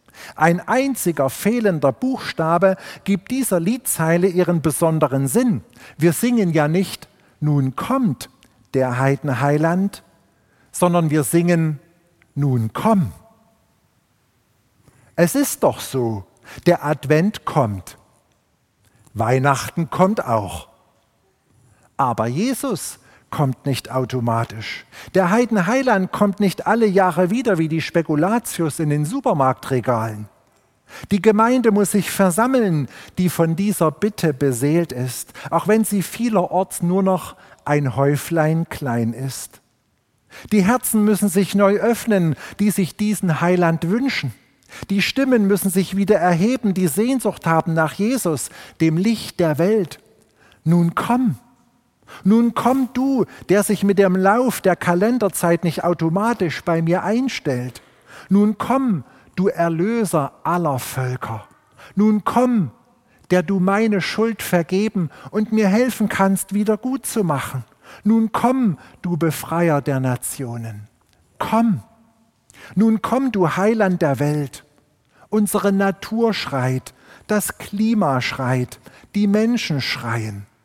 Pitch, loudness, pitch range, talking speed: 175 Hz, -19 LUFS, 140-210 Hz, 120 wpm